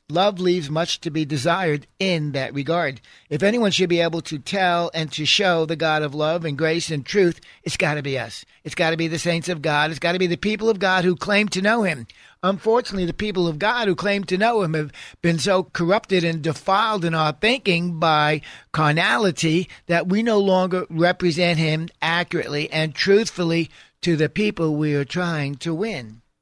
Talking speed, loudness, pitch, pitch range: 205 wpm, -21 LUFS, 170 Hz, 155-185 Hz